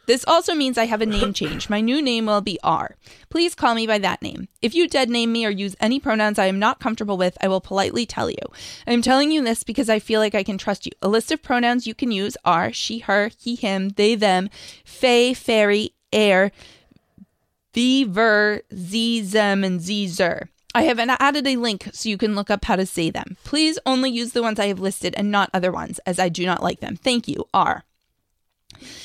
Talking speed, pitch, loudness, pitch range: 235 wpm, 220 Hz, -20 LUFS, 200-240 Hz